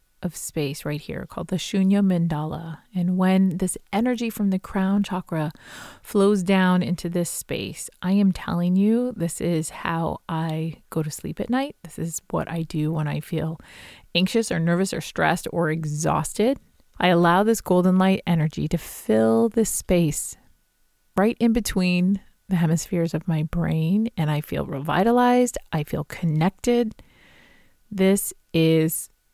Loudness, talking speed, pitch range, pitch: -23 LUFS, 155 wpm, 160-195 Hz, 175 Hz